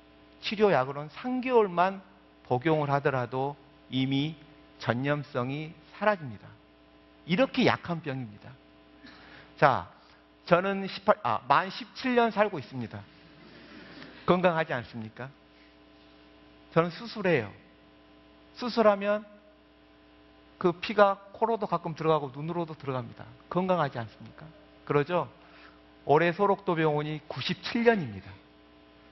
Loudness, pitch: -28 LUFS, 140 Hz